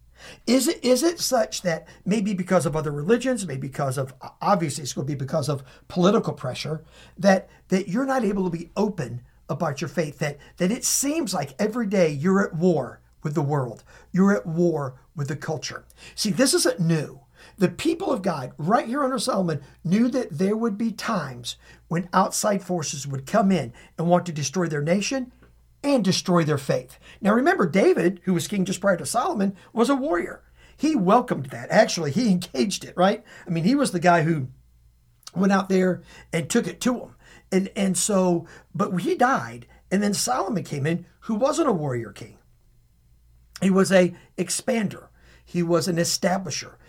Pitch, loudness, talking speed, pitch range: 180 Hz, -24 LUFS, 190 wpm, 155-205 Hz